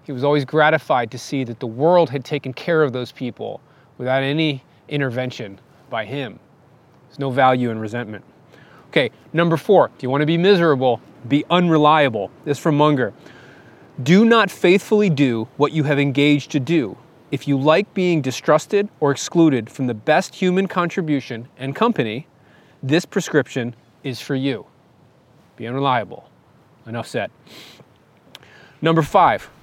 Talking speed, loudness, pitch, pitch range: 150 wpm, -19 LUFS, 145 Hz, 130-160 Hz